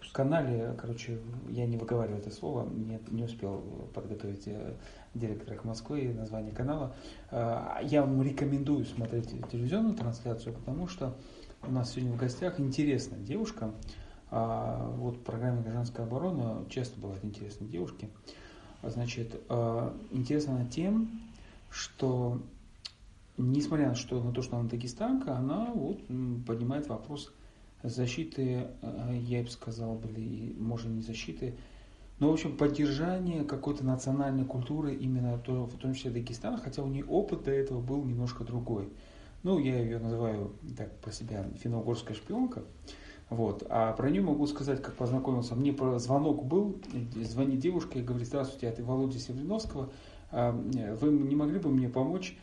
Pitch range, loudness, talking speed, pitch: 115-135 Hz, -34 LUFS, 135 wpm, 120 Hz